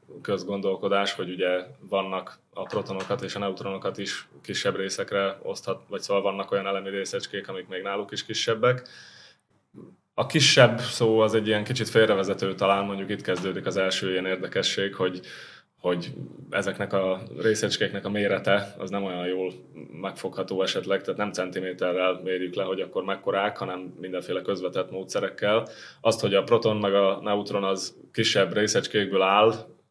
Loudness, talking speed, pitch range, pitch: -26 LUFS, 150 wpm, 95-100 Hz, 100 Hz